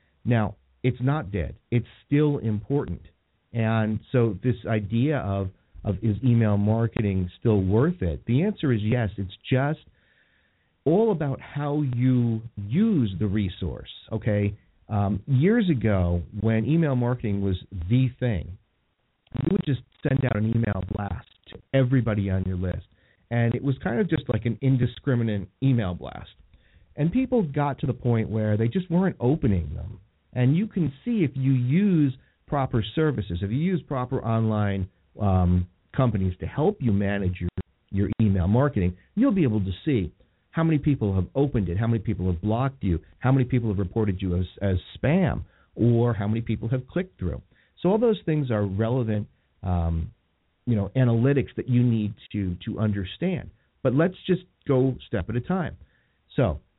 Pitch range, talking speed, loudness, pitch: 100-135 Hz, 170 wpm, -25 LUFS, 115 Hz